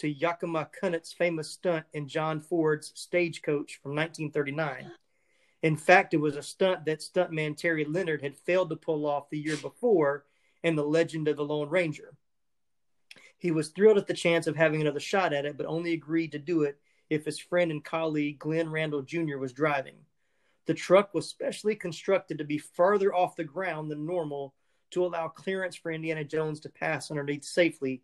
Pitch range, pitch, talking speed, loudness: 150-175 Hz, 160 Hz, 185 wpm, -29 LUFS